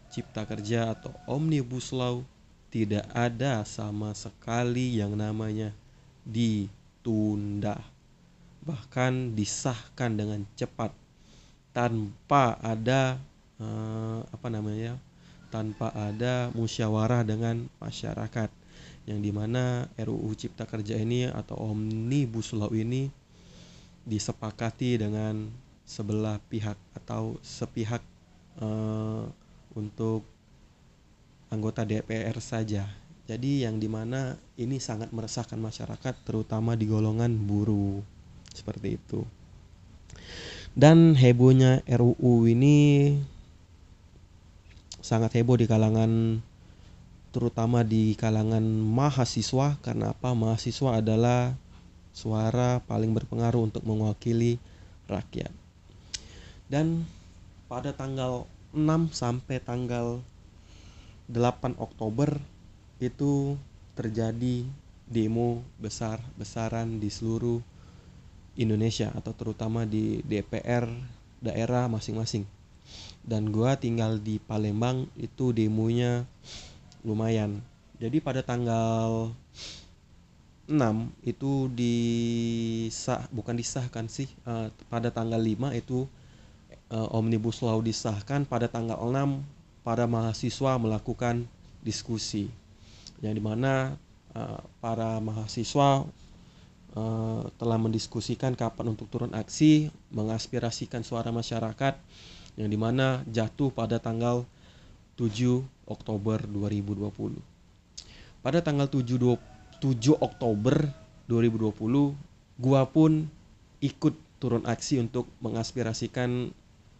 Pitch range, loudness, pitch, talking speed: 110-125 Hz, -29 LUFS, 115 Hz, 90 wpm